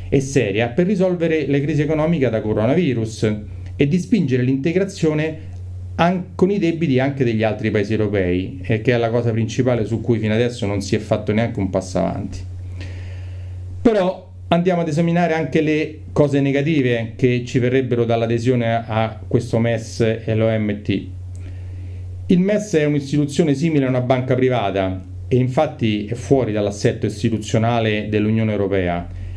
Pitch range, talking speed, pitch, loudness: 100-140 Hz, 150 wpm, 115 Hz, -19 LUFS